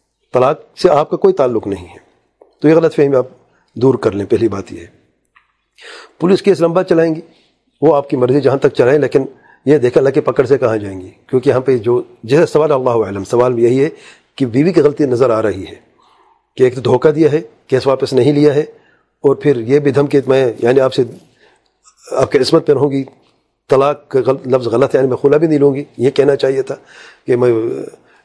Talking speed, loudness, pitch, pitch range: 225 wpm, -13 LUFS, 140 Hz, 130-165 Hz